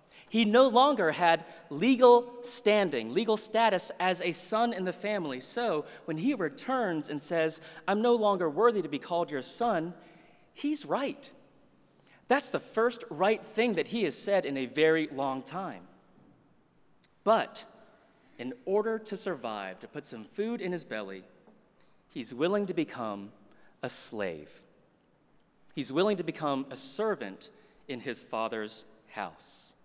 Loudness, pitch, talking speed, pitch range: -29 LUFS, 180 Hz, 145 wpm, 150-225 Hz